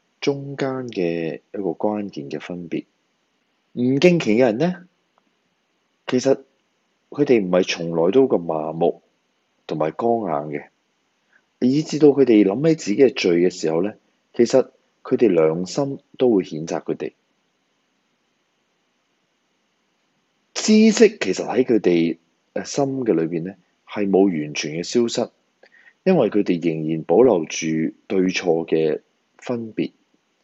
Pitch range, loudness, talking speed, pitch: 80-135 Hz, -20 LUFS, 185 characters per minute, 105 Hz